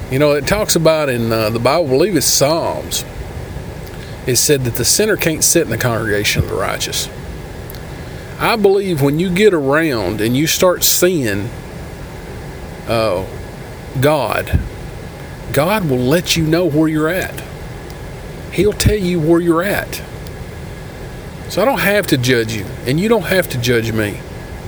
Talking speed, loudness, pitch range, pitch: 165 wpm, -15 LUFS, 120-175 Hz, 150 Hz